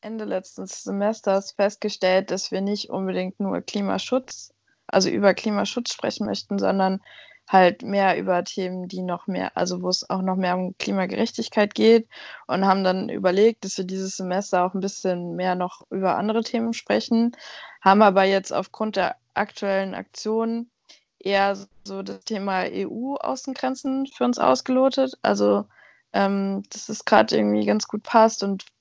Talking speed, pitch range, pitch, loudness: 155 wpm, 185-225 Hz, 195 Hz, -23 LUFS